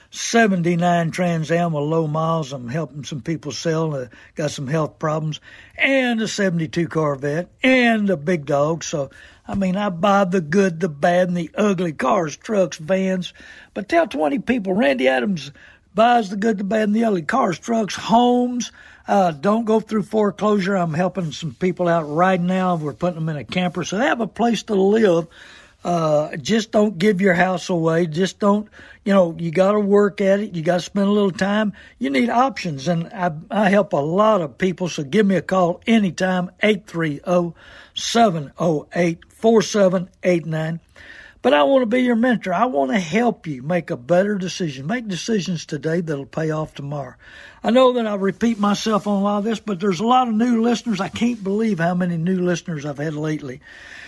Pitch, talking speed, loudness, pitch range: 185 Hz, 190 wpm, -20 LUFS, 165-210 Hz